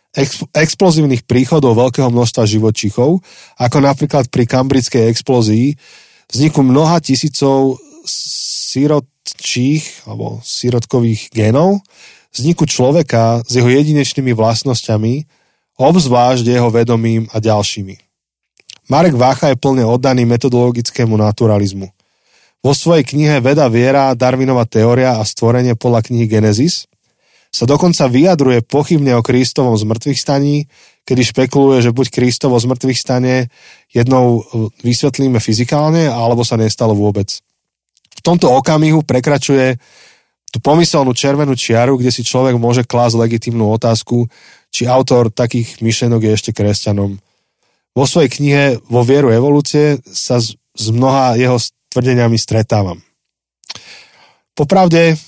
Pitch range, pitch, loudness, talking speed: 115-140 Hz, 125 Hz, -12 LUFS, 115 wpm